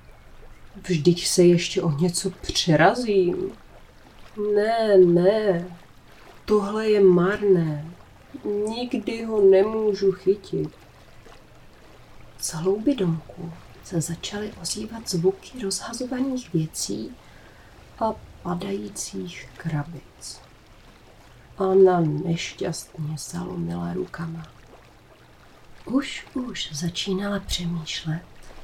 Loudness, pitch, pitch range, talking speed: -23 LUFS, 185 Hz, 165-205 Hz, 75 wpm